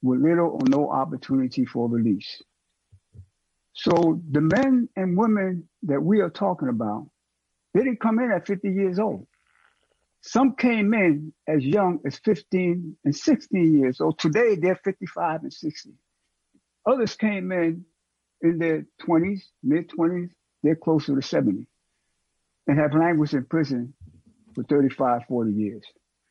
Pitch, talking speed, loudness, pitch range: 165 Hz, 140 wpm, -23 LUFS, 140-205 Hz